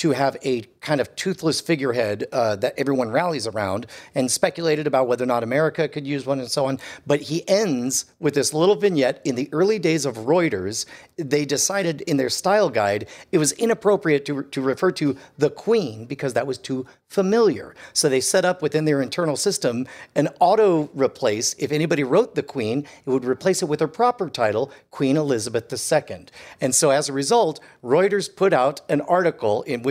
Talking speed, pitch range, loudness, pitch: 195 wpm, 135-175 Hz, -22 LUFS, 150 Hz